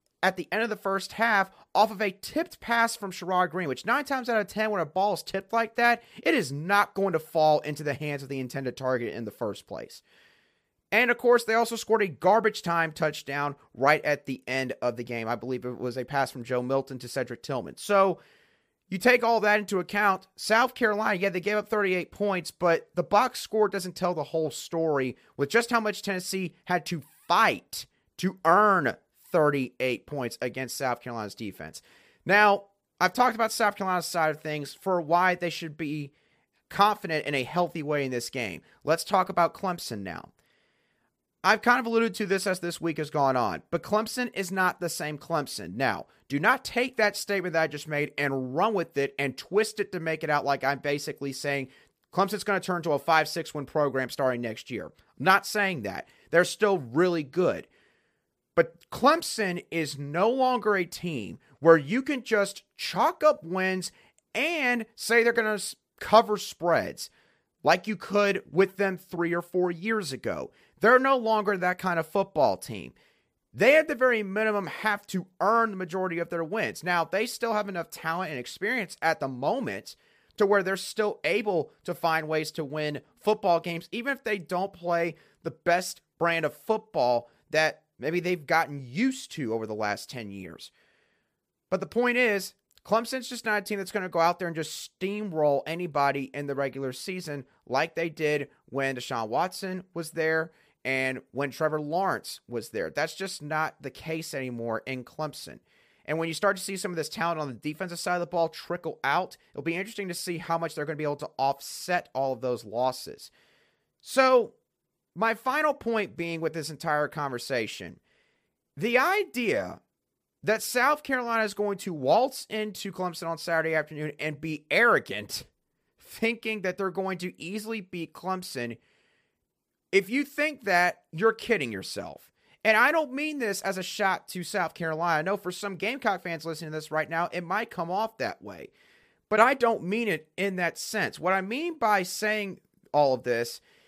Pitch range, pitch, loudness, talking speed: 150-210 Hz, 180 Hz, -27 LUFS, 195 wpm